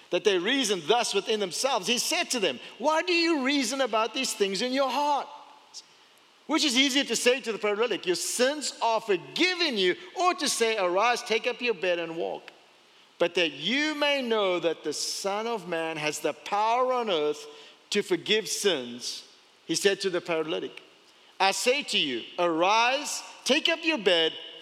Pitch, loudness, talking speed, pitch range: 235 Hz, -26 LUFS, 185 wpm, 195-290 Hz